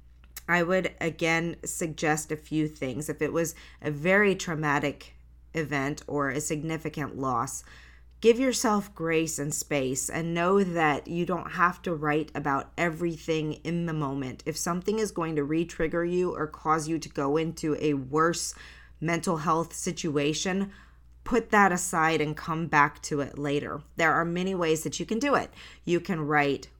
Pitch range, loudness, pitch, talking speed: 145-170 Hz, -28 LUFS, 160 Hz, 170 wpm